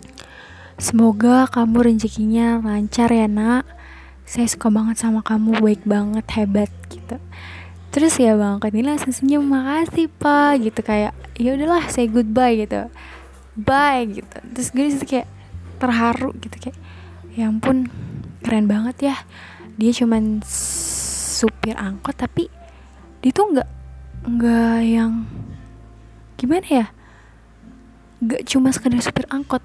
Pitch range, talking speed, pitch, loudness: 195-255 Hz, 125 wpm, 225 Hz, -19 LUFS